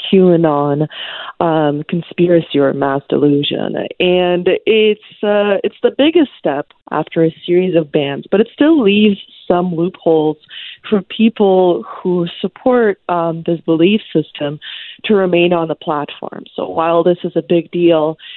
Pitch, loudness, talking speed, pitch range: 175 Hz, -14 LUFS, 145 wpm, 160-200 Hz